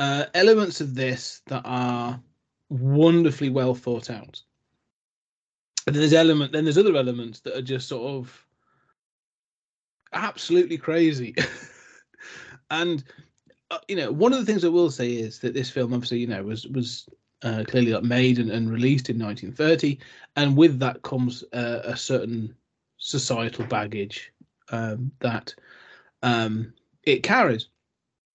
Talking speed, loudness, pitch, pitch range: 140 wpm, -24 LUFS, 130 Hz, 120-145 Hz